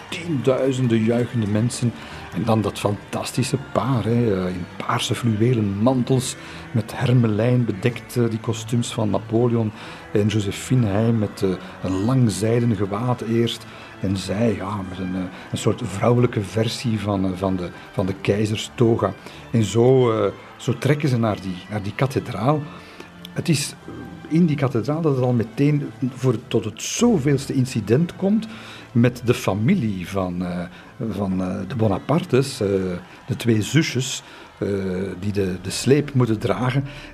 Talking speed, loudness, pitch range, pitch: 145 wpm, -22 LUFS, 100-125 Hz, 115 Hz